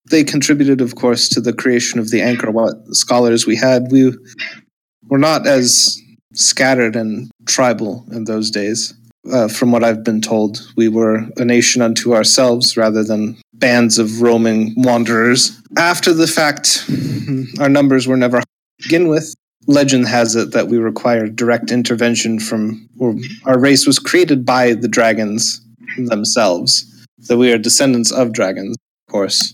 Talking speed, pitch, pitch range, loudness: 160 wpm, 120 Hz, 115-130 Hz, -13 LUFS